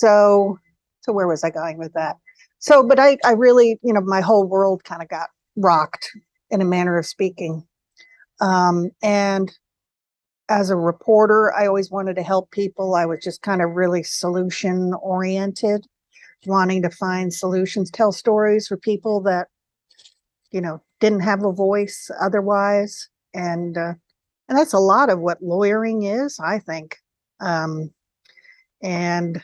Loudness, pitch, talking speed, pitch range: -19 LUFS, 195 Hz, 155 wpm, 175-210 Hz